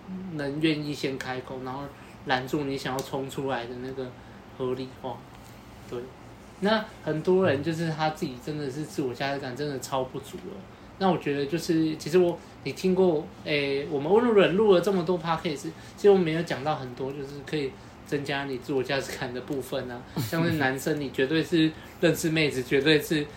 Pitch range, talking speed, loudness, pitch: 130-165 Hz, 300 characters per minute, -27 LUFS, 145 Hz